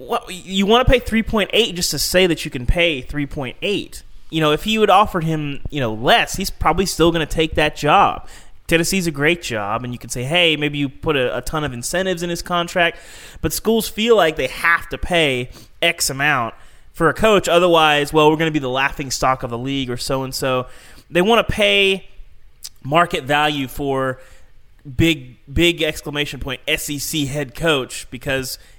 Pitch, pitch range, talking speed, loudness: 150 Hz, 135-175 Hz, 200 wpm, -18 LUFS